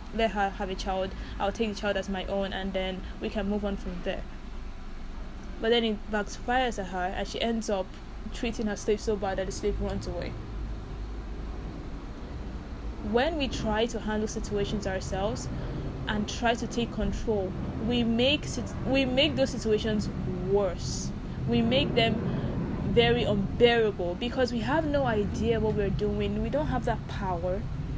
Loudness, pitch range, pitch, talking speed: -29 LUFS, 195-235 Hz, 215 Hz, 165 wpm